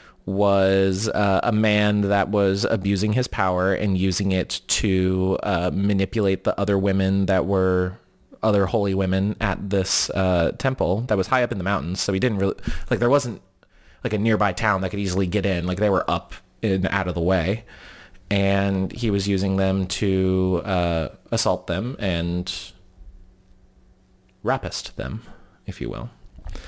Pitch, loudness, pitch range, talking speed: 95 Hz, -22 LUFS, 95-100 Hz, 165 wpm